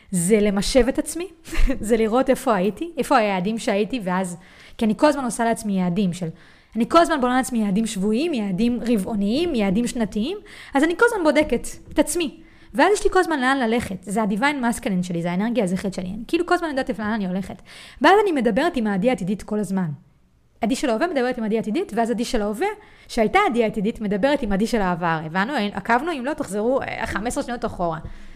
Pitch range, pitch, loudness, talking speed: 205-275 Hz, 230 Hz, -22 LUFS, 180 wpm